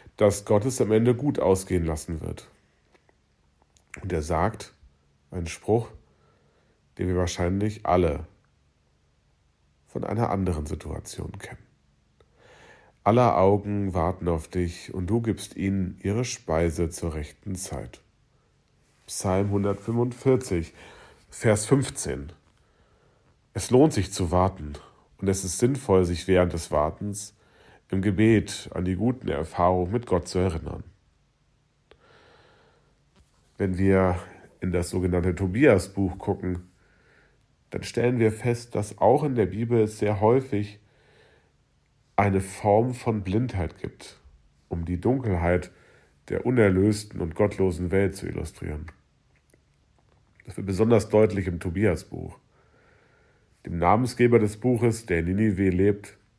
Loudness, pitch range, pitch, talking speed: -25 LUFS, 90-105 Hz, 95 Hz, 120 wpm